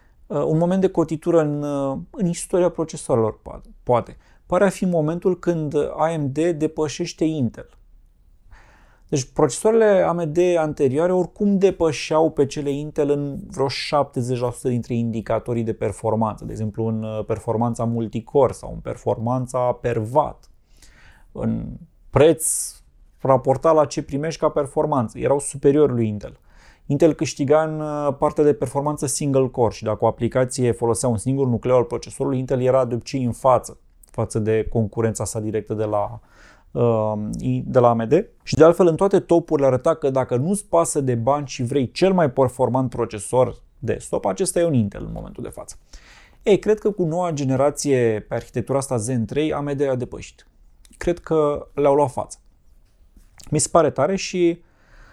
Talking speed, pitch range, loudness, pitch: 155 wpm, 115-155 Hz, -21 LUFS, 135 Hz